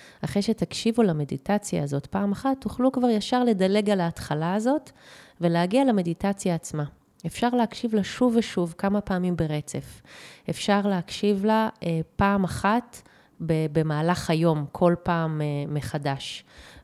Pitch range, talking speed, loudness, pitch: 165-215 Hz, 130 wpm, -25 LUFS, 190 Hz